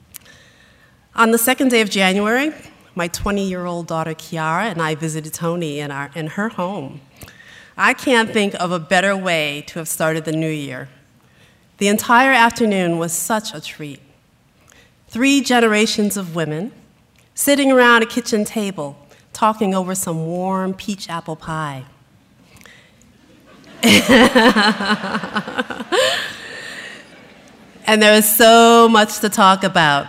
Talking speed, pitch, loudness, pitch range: 125 wpm, 195 Hz, -16 LUFS, 160-225 Hz